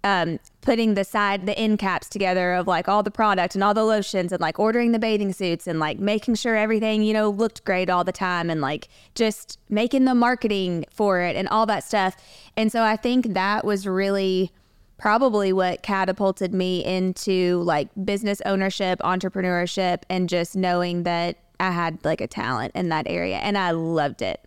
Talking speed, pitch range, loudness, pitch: 195 wpm, 180-215 Hz, -23 LUFS, 190 Hz